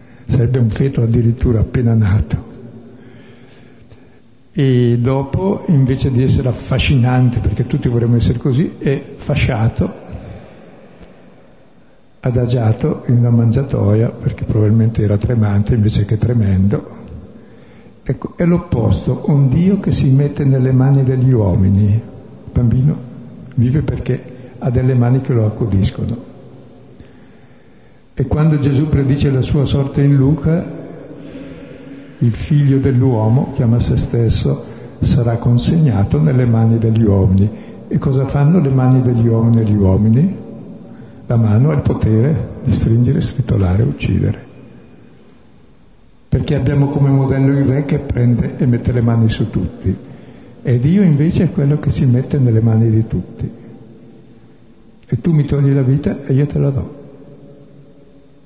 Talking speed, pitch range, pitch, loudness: 130 wpm, 115-140 Hz, 125 Hz, -15 LUFS